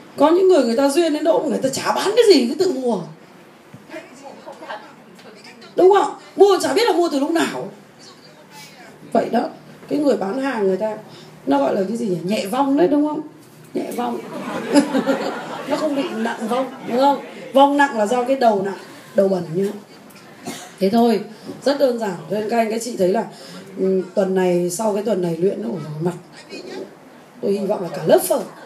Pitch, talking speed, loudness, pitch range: 230 Hz, 200 wpm, -19 LUFS, 195-280 Hz